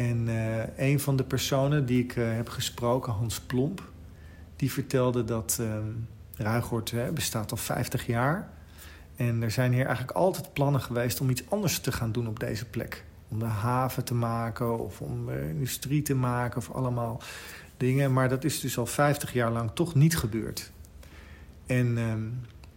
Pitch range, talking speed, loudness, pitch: 110-130 Hz, 170 wpm, -29 LUFS, 120 Hz